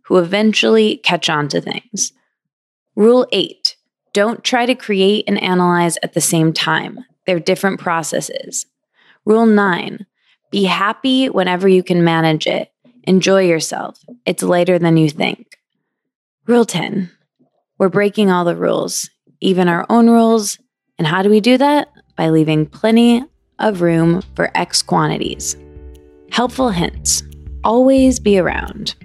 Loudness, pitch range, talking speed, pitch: -15 LUFS, 170-220 Hz, 140 wpm, 190 Hz